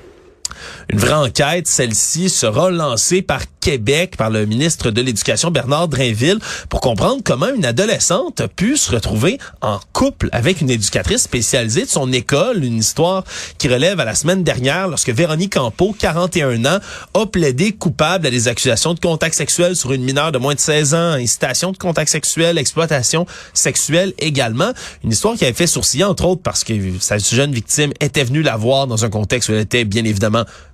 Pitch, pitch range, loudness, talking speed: 145 Hz, 120-175 Hz, -15 LUFS, 185 wpm